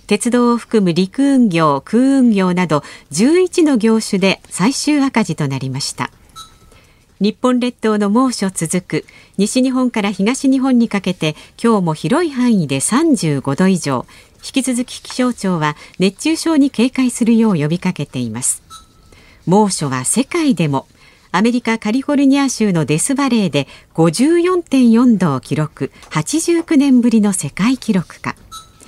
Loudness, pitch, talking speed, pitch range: -15 LUFS, 220 Hz, 260 characters per minute, 165-255 Hz